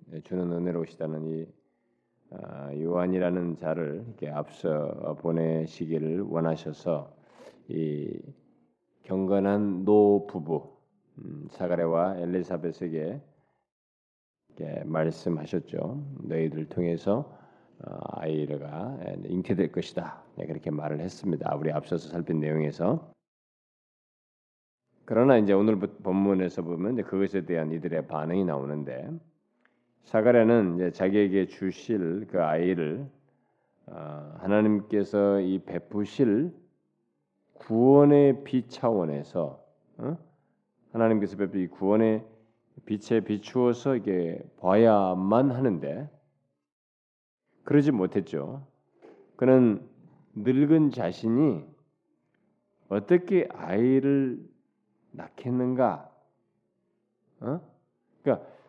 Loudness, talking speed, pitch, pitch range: -27 LUFS, 220 characters per minute, 95 Hz, 80-120 Hz